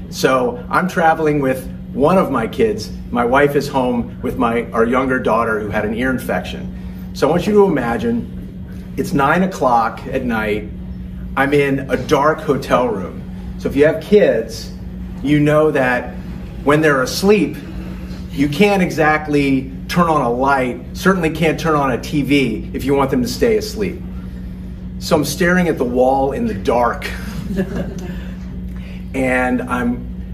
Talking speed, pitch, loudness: 160 wpm, 140 Hz, -16 LUFS